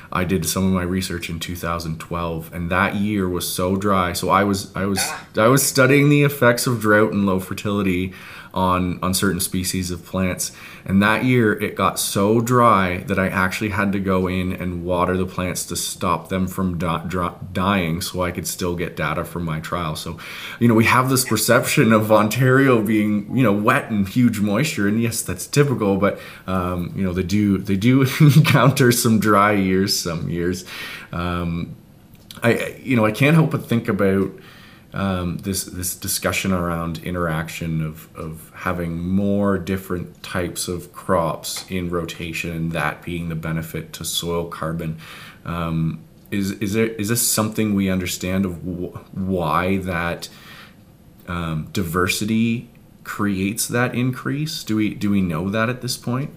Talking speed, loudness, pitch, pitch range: 175 wpm, -20 LUFS, 95 Hz, 90-110 Hz